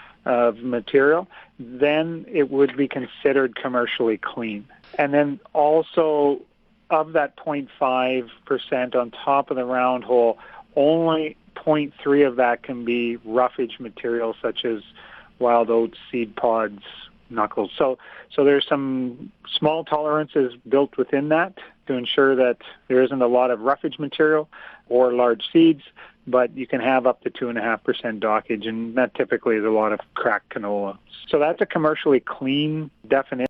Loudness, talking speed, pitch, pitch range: -22 LUFS, 145 wpm, 130 Hz, 120-150 Hz